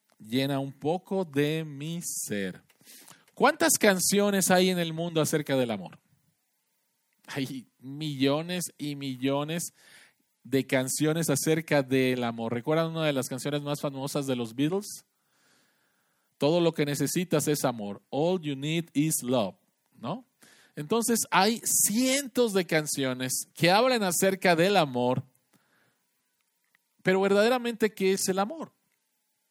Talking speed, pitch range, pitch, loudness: 125 wpm, 135-185 Hz, 155 Hz, -27 LUFS